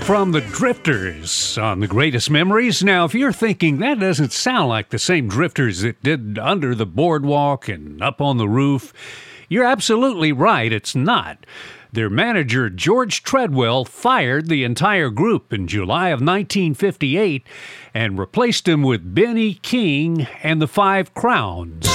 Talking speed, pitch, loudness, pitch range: 150 wpm, 145 Hz, -18 LUFS, 115-185 Hz